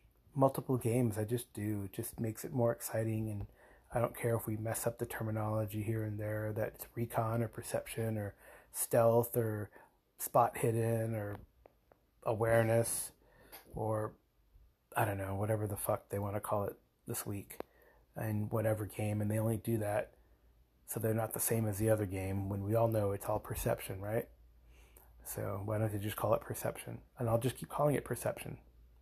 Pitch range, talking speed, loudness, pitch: 100-115 Hz, 185 wpm, -36 LUFS, 110 Hz